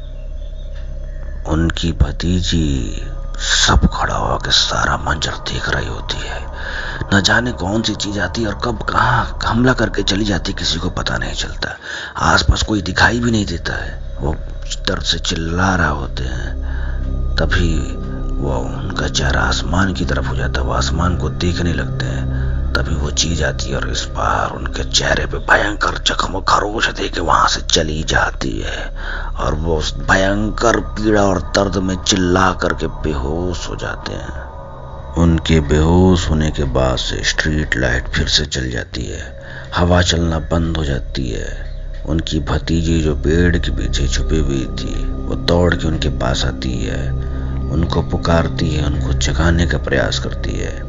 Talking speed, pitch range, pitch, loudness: 165 wpm, 65-85 Hz, 75 Hz, -17 LUFS